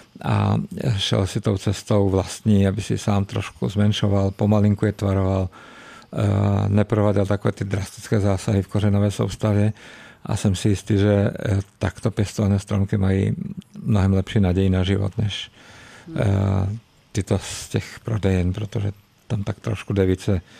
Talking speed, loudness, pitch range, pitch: 135 wpm, -22 LUFS, 100-110 Hz, 105 Hz